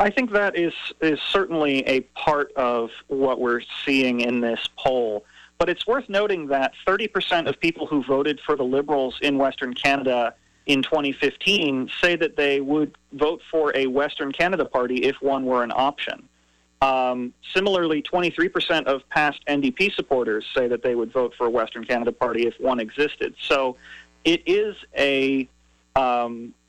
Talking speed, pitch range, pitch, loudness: 165 wpm, 125-160 Hz, 140 Hz, -22 LUFS